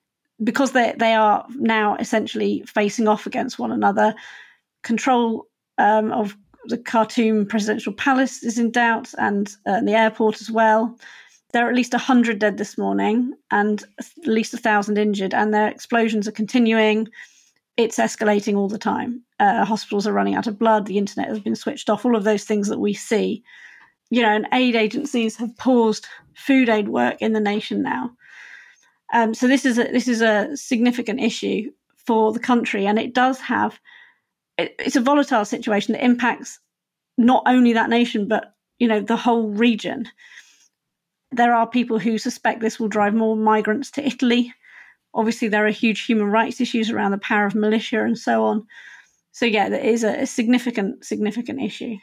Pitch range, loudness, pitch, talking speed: 215-245 Hz, -20 LUFS, 225 Hz, 180 wpm